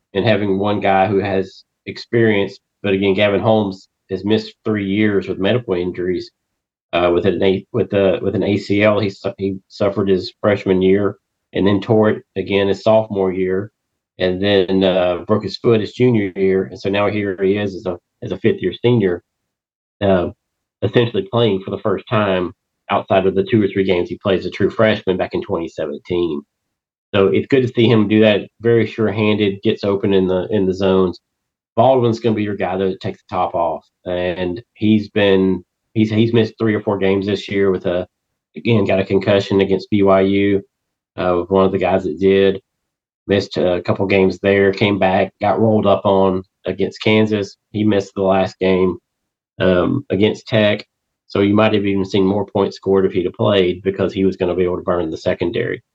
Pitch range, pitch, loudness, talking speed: 95-105 Hz, 100 Hz, -17 LUFS, 200 wpm